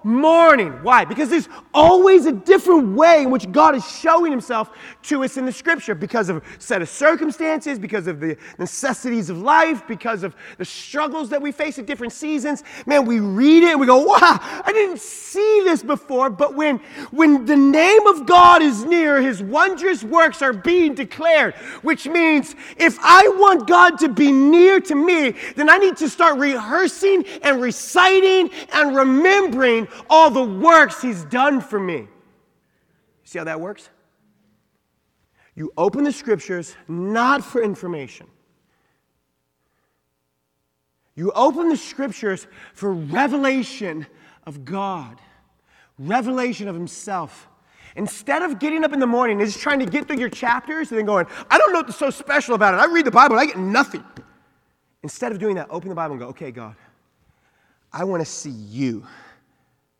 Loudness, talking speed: -16 LUFS, 170 wpm